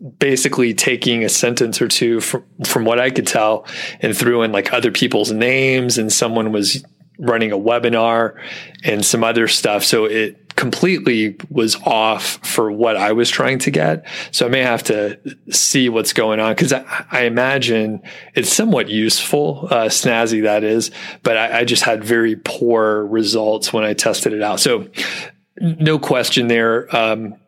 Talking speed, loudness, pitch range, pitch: 175 wpm, -16 LUFS, 110-125 Hz, 115 Hz